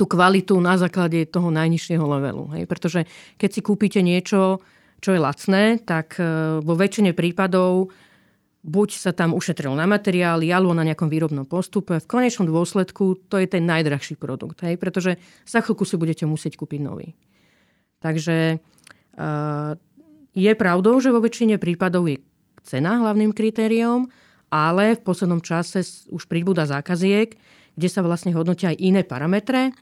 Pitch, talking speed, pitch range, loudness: 180 Hz, 145 wpm, 165-200 Hz, -21 LUFS